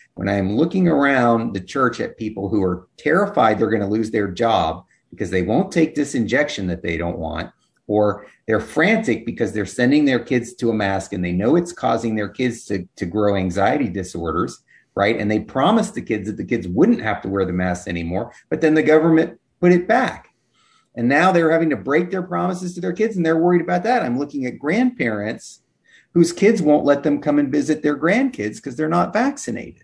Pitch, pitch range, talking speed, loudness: 130 Hz, 105-165 Hz, 215 wpm, -19 LUFS